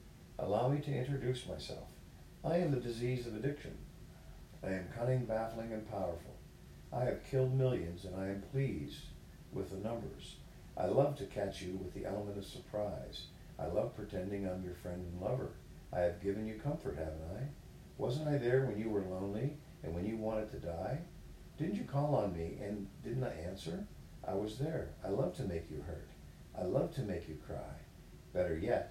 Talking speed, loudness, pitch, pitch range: 190 wpm, -39 LUFS, 105 Hz, 95-130 Hz